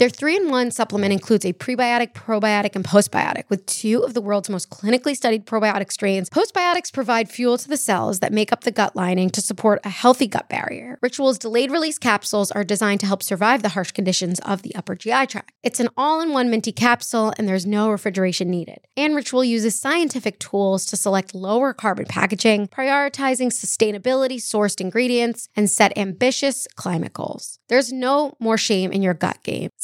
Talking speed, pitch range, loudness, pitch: 185 wpm, 200-255 Hz, -20 LUFS, 225 Hz